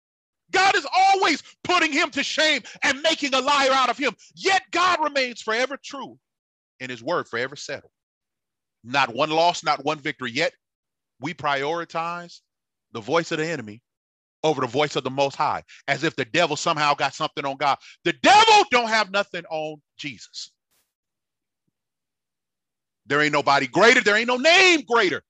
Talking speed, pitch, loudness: 165 wpm, 175 Hz, -21 LUFS